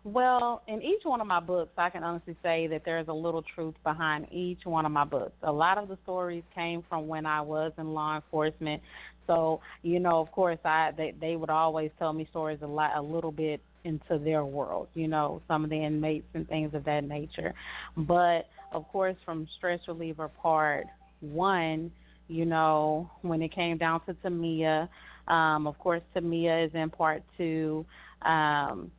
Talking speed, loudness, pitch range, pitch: 195 wpm, -30 LUFS, 155-170 Hz, 160 Hz